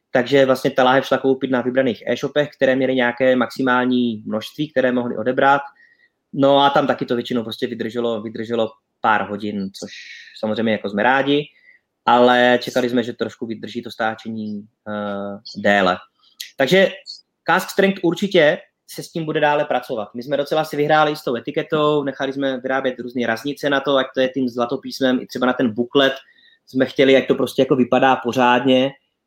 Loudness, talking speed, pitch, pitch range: -19 LUFS, 180 wpm, 130 Hz, 120-140 Hz